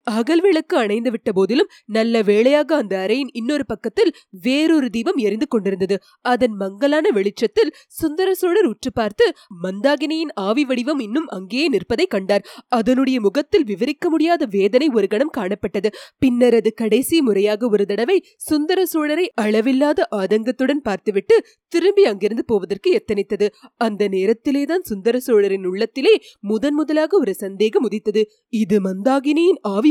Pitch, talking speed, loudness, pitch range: 245 Hz, 130 wpm, -18 LUFS, 210-310 Hz